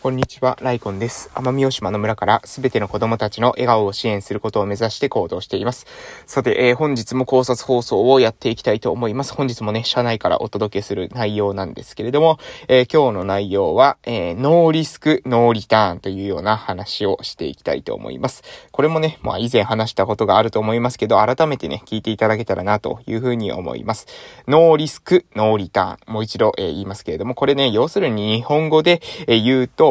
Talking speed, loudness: 445 characters per minute, -18 LUFS